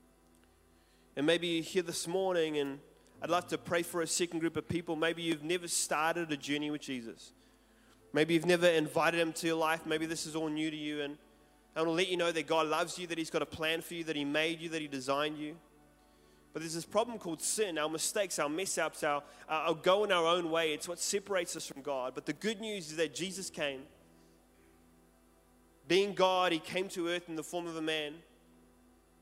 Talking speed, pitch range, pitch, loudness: 225 wpm, 145-170 Hz, 160 Hz, -34 LUFS